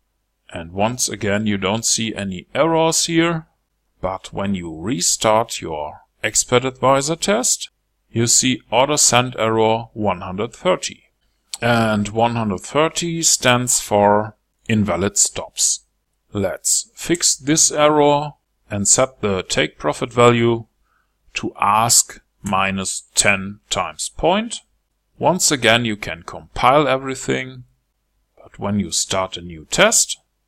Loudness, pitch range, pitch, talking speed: -17 LUFS, 100-135 Hz, 115 Hz, 115 wpm